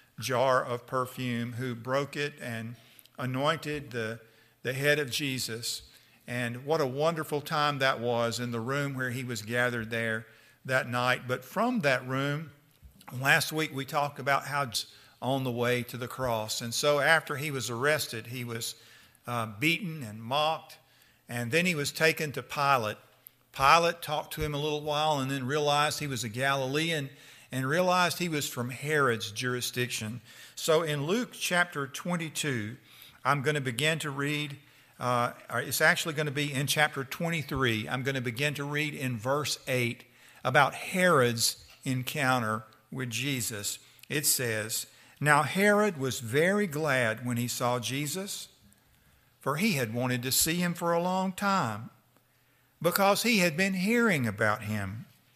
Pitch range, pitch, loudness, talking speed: 120-150 Hz, 135 Hz, -29 LUFS, 165 wpm